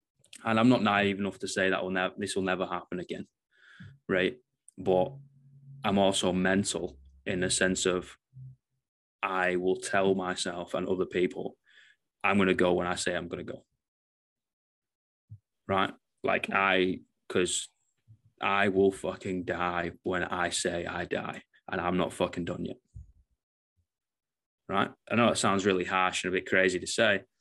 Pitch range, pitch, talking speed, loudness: 90-110 Hz, 95 Hz, 160 wpm, -29 LUFS